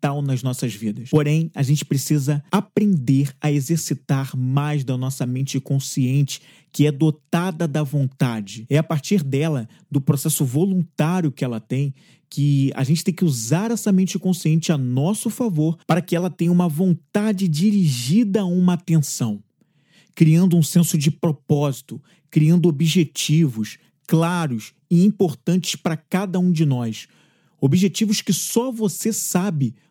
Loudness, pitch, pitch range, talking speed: -20 LUFS, 155 Hz, 140-180 Hz, 145 wpm